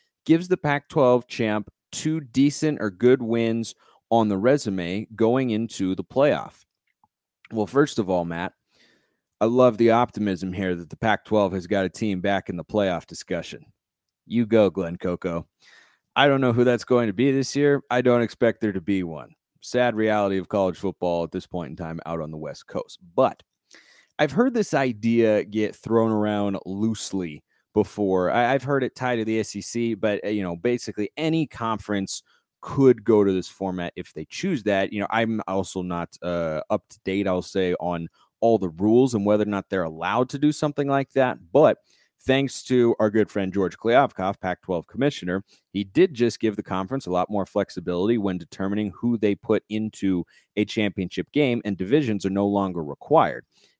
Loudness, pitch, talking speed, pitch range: -24 LUFS, 105 Hz, 190 wpm, 95-120 Hz